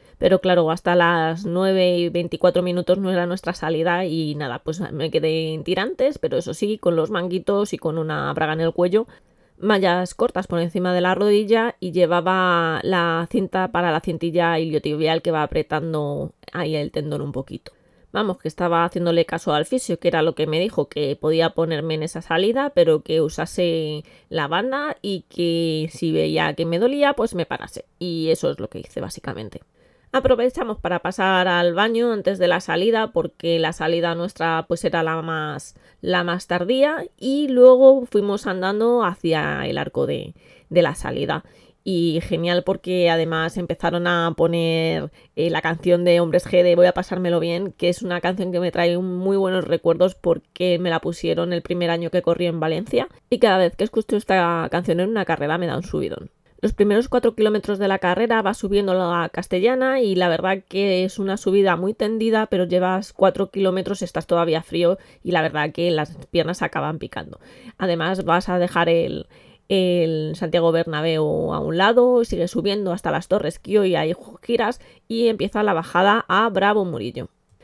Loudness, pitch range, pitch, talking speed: -20 LUFS, 165-195 Hz, 175 Hz, 190 wpm